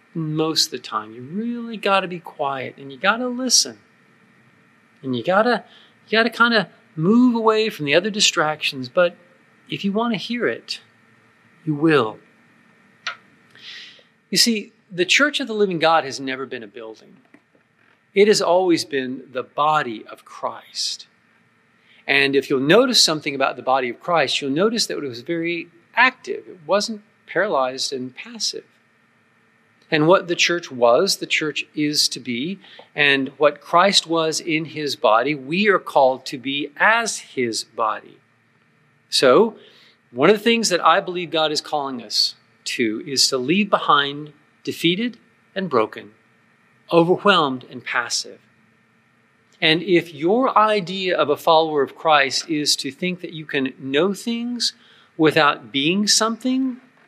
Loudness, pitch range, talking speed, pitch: -19 LUFS, 140-210 Hz, 160 wpm, 170 Hz